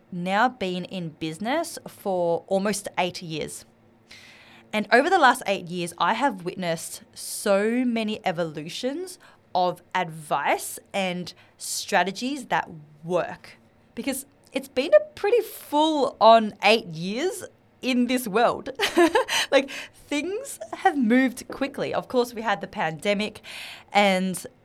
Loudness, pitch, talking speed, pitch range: -24 LUFS, 210 Hz, 120 wpm, 175-265 Hz